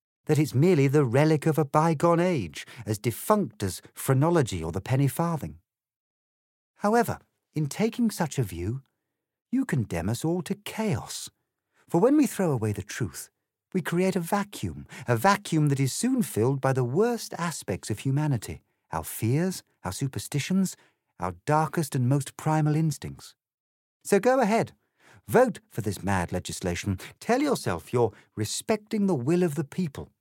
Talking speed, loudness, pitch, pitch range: 155 wpm, -27 LUFS, 150 Hz, 110-180 Hz